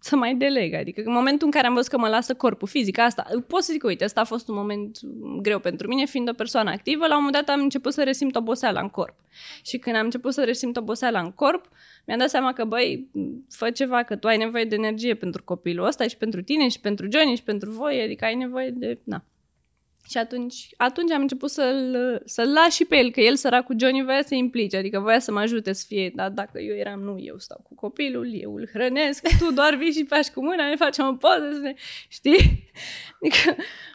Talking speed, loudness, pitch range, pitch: 235 wpm, -23 LUFS, 220-280 Hz, 245 Hz